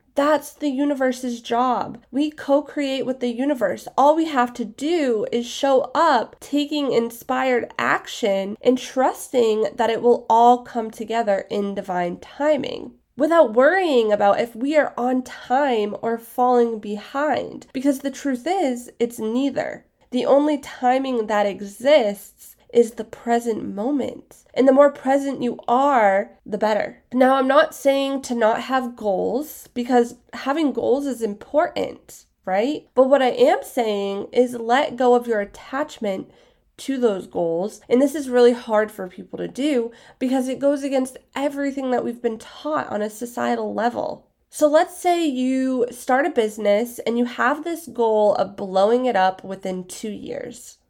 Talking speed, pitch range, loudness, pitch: 160 wpm, 225-275 Hz, -21 LUFS, 250 Hz